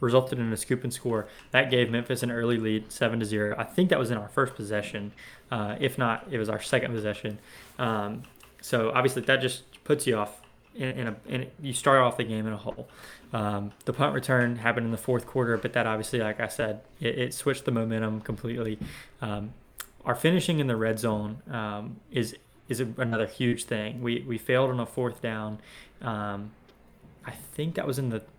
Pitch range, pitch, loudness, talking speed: 110-130 Hz, 120 Hz, -29 LUFS, 210 wpm